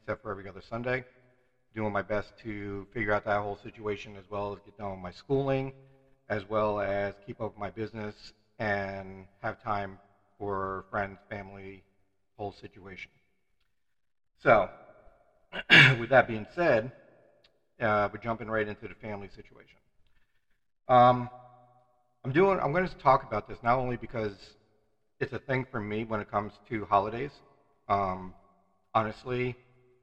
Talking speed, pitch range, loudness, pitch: 150 wpm, 100-125 Hz, -29 LUFS, 105 Hz